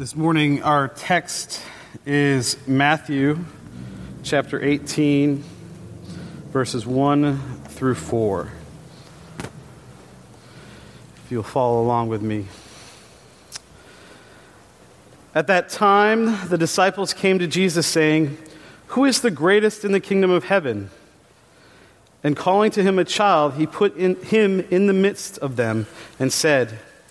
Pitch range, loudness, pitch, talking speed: 125-185 Hz, -20 LUFS, 150 Hz, 115 wpm